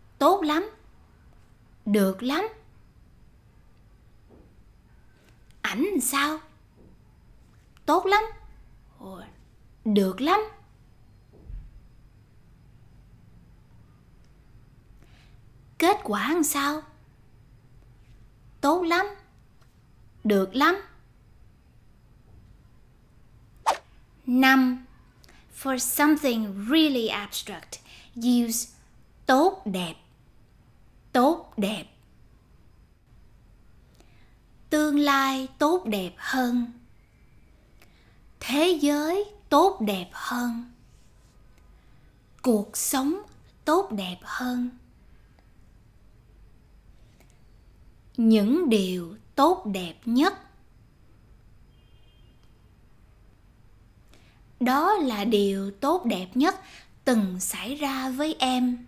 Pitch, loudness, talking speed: 240 Hz, -25 LUFS, 60 wpm